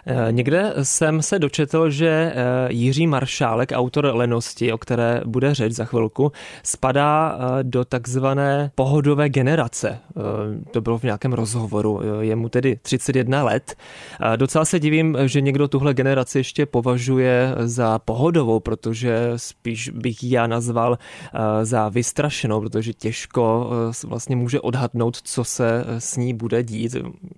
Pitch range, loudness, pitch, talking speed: 115-140 Hz, -20 LUFS, 125 Hz, 130 wpm